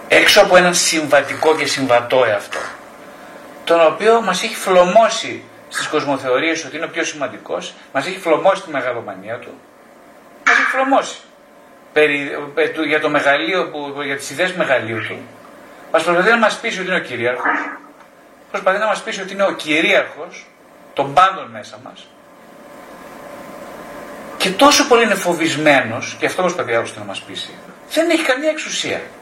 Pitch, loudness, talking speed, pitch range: 170 Hz, -16 LUFS, 155 wpm, 150-205 Hz